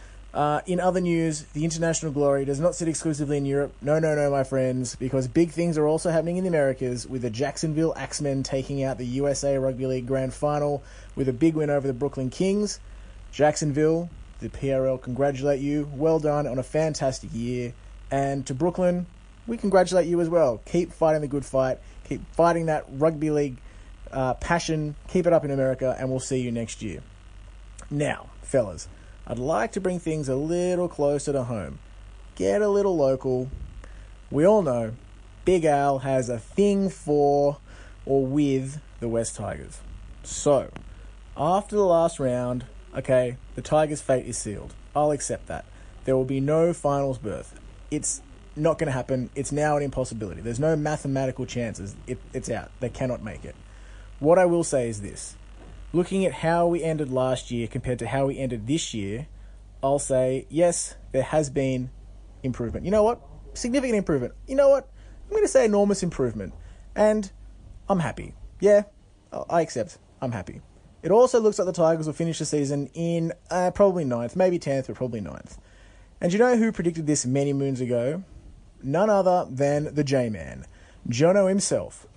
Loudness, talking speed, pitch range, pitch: -25 LUFS, 180 wpm, 120-160 Hz, 140 Hz